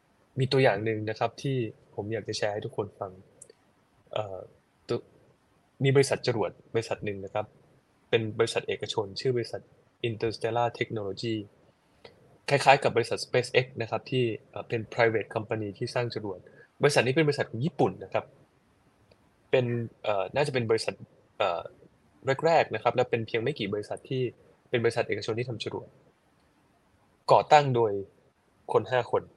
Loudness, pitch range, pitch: -28 LUFS, 110-130 Hz, 115 Hz